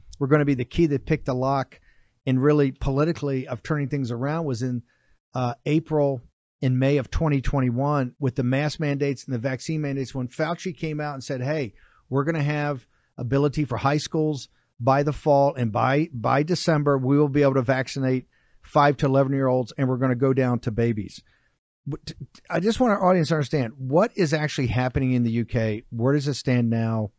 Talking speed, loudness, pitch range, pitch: 205 wpm, -24 LUFS, 130-150 Hz, 140 Hz